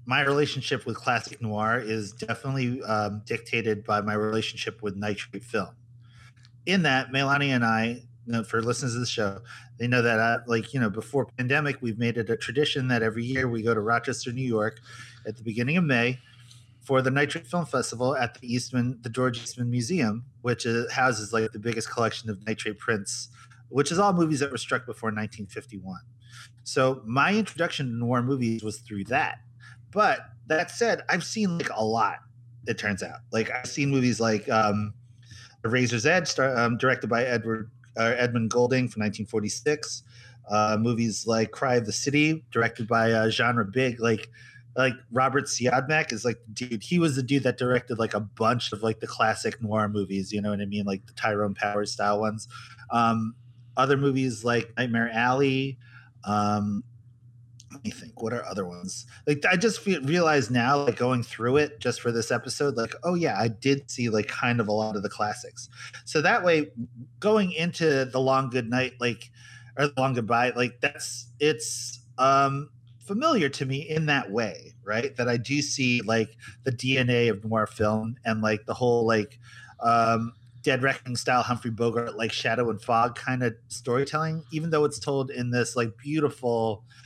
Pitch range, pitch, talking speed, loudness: 115-130 Hz, 120 Hz, 190 wpm, -26 LUFS